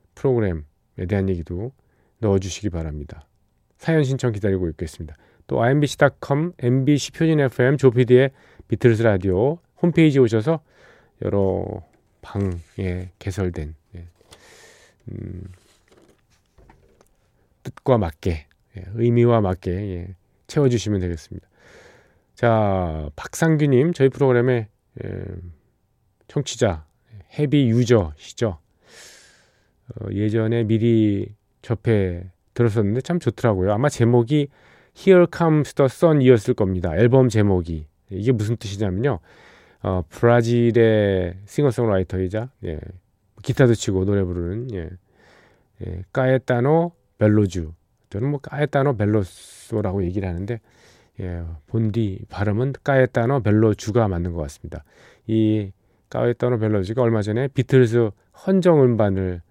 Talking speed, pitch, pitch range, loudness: 265 characters per minute, 110 Hz, 95-125 Hz, -20 LUFS